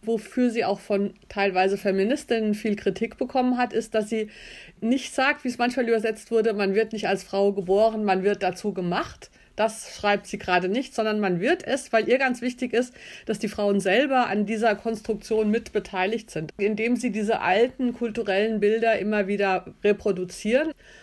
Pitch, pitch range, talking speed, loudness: 220 Hz, 200-235 Hz, 175 wpm, -24 LUFS